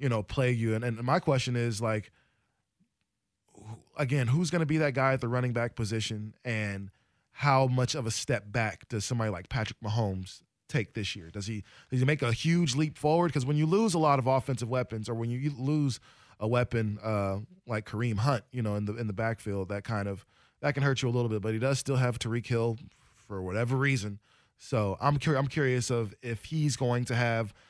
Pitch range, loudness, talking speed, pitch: 110-135 Hz, -30 LUFS, 225 wpm, 120 Hz